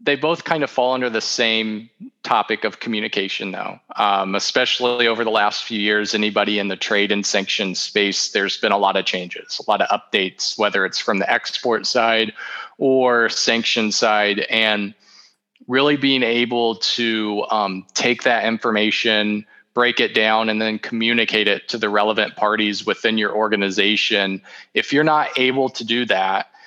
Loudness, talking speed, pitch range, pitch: -18 LUFS, 170 wpm, 105-120 Hz, 110 Hz